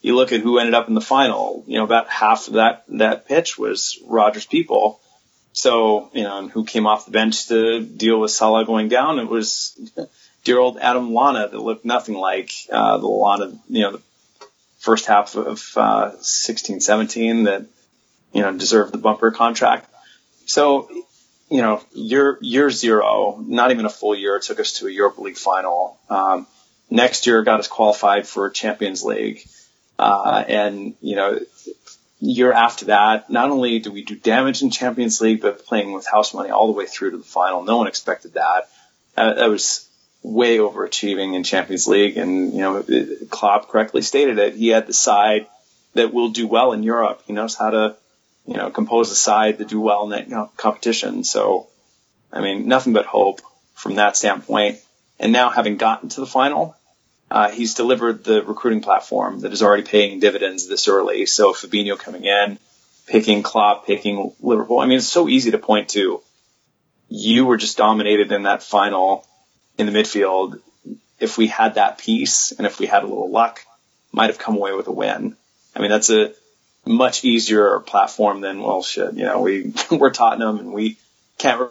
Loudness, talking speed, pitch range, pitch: -18 LUFS, 190 wpm, 105-125 Hz, 110 Hz